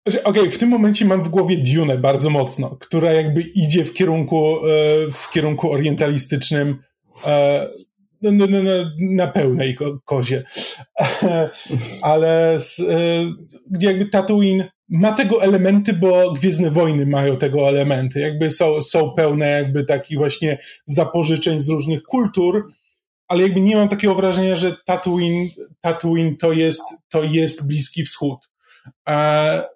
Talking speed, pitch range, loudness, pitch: 125 wpm, 150-185 Hz, -17 LUFS, 165 Hz